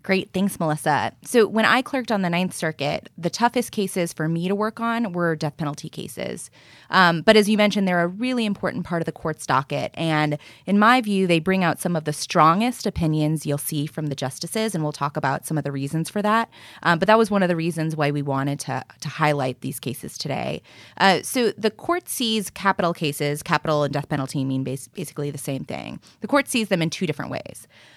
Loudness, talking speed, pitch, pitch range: -22 LUFS, 225 wpm, 170 Hz, 150-205 Hz